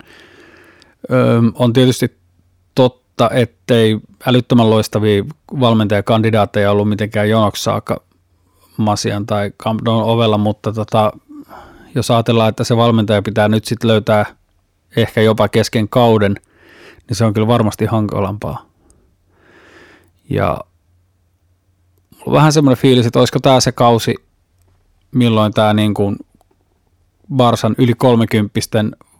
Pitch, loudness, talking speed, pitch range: 110 Hz, -14 LUFS, 105 wpm, 100-120 Hz